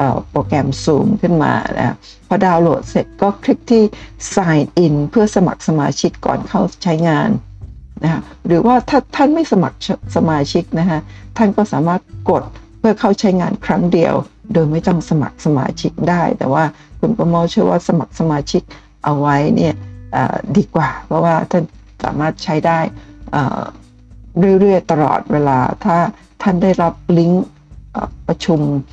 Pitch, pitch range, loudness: 170 Hz, 145-195 Hz, -15 LUFS